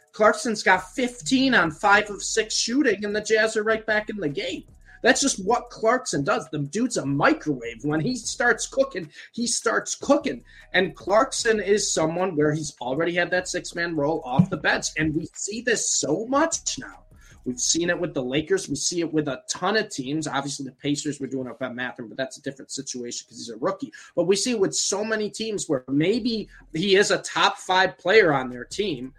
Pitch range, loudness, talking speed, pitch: 145-220 Hz, -23 LUFS, 220 wpm, 185 Hz